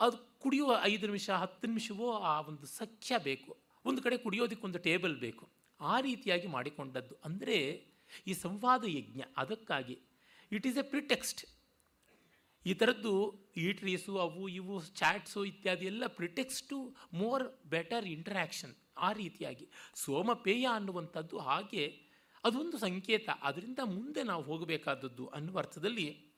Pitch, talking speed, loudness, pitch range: 195 Hz, 125 wpm, -37 LUFS, 170-235 Hz